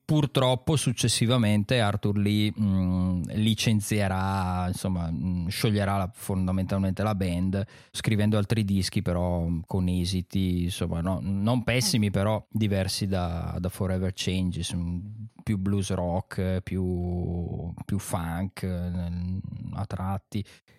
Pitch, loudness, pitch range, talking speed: 95 Hz, -27 LUFS, 90-105 Hz, 110 wpm